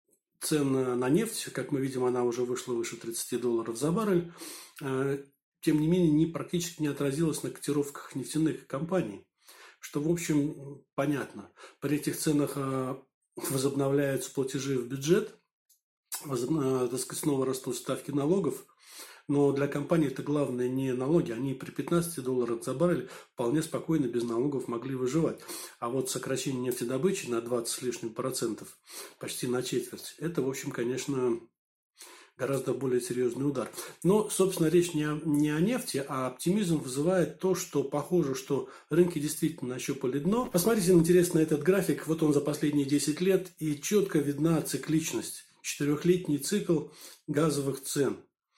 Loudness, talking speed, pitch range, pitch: -30 LUFS, 145 wpm, 130-165 Hz, 145 Hz